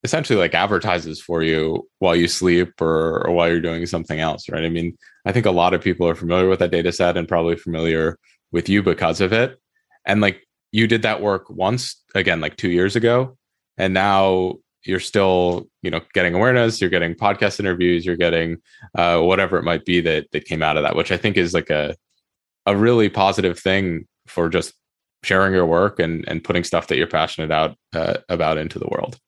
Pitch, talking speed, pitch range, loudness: 90 Hz, 210 wpm, 85-95 Hz, -19 LUFS